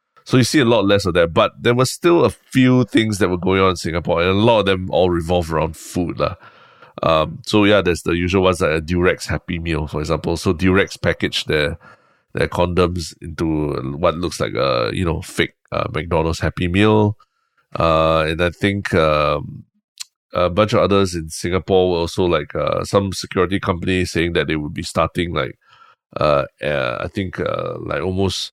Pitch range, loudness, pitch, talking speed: 80-100 Hz, -18 LUFS, 90 Hz, 200 wpm